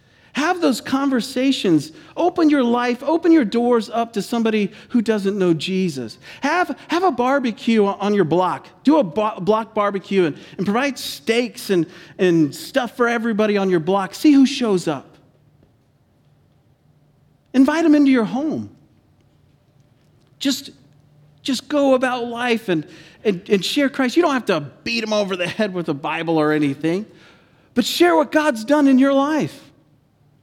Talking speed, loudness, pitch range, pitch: 160 wpm, -19 LUFS, 165-265 Hz, 215 Hz